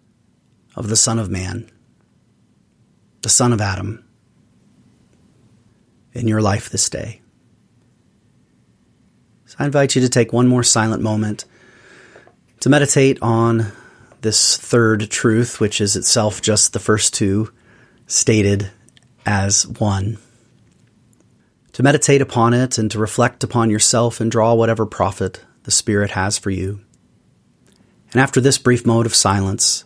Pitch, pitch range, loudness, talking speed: 115 Hz, 105-120 Hz, -16 LUFS, 130 wpm